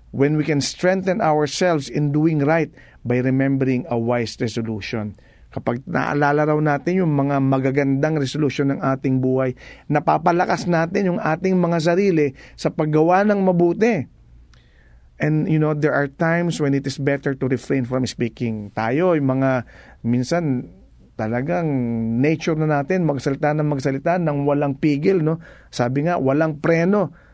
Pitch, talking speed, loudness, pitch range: 145 Hz, 145 wpm, -20 LUFS, 130-165 Hz